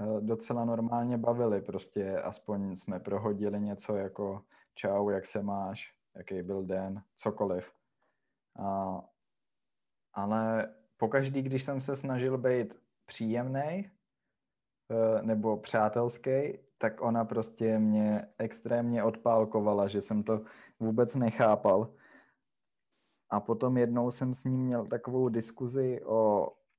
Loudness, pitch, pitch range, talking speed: -32 LUFS, 115 Hz, 105-120 Hz, 110 wpm